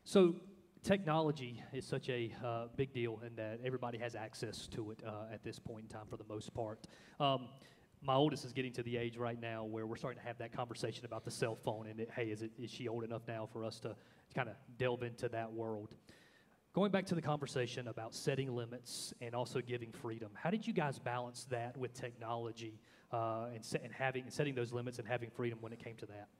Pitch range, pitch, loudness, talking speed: 115-130 Hz, 120 Hz, -42 LUFS, 230 wpm